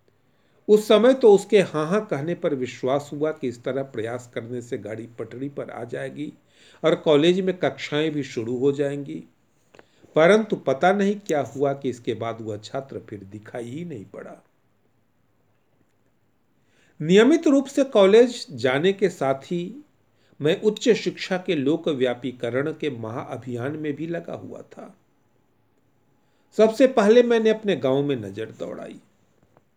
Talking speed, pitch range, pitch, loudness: 145 wpm, 130-195 Hz, 150 Hz, -22 LUFS